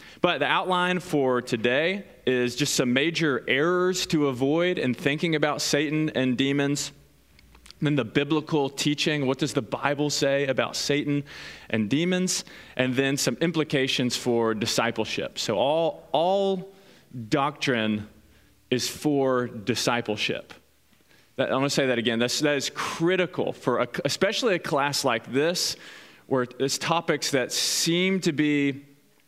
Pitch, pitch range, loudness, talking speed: 140 Hz, 125-155 Hz, -25 LUFS, 145 wpm